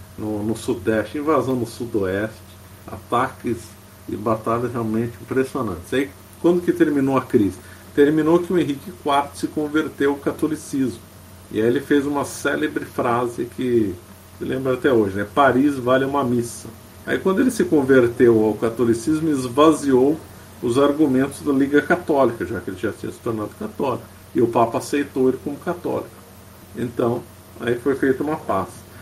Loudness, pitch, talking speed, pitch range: -21 LUFS, 125 Hz, 160 wpm, 110-145 Hz